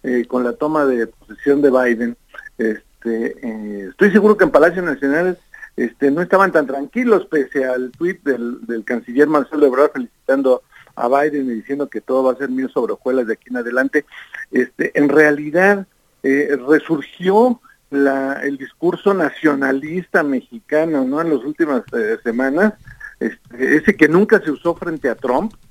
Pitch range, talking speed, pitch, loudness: 130-185 Hz, 165 wpm, 145 Hz, -17 LUFS